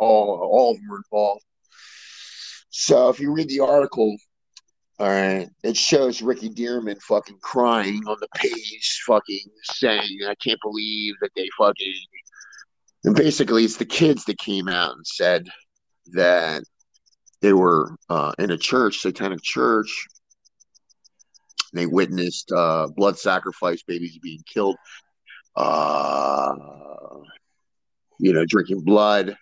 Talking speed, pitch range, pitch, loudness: 130 wpm, 95-120 Hz, 105 Hz, -21 LUFS